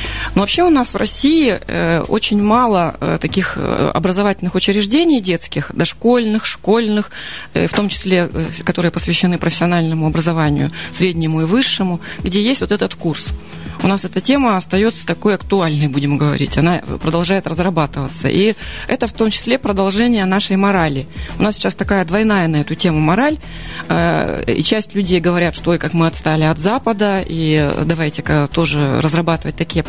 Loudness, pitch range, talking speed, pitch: -16 LUFS, 160-210 Hz, 150 wpm, 180 Hz